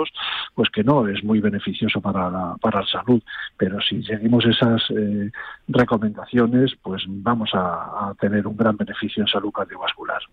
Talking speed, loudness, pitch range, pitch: 165 wpm, -21 LUFS, 100-120 Hz, 110 Hz